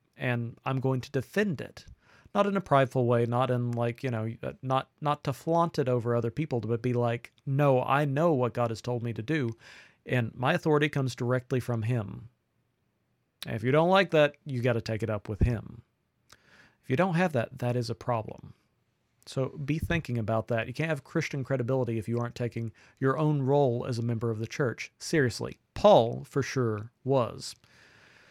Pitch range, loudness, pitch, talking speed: 115-140 Hz, -29 LUFS, 125 Hz, 200 wpm